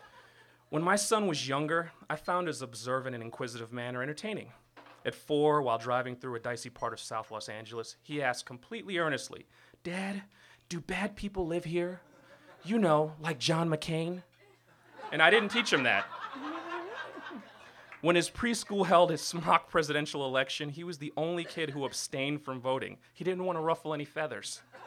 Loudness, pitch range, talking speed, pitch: -32 LUFS, 130-175 Hz, 170 wpm, 155 Hz